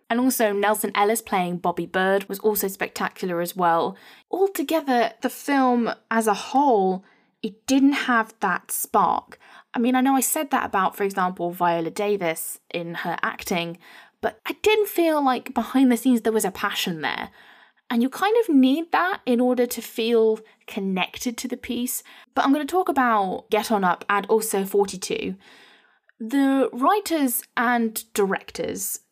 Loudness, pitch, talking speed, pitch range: -23 LUFS, 230 Hz, 165 wpm, 200-260 Hz